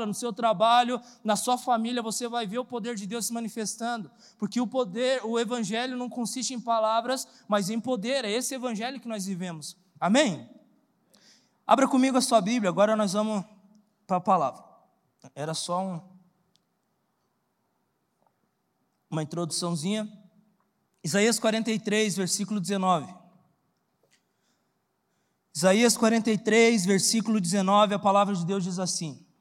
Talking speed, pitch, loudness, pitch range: 130 wpm, 215 Hz, -26 LUFS, 195-235 Hz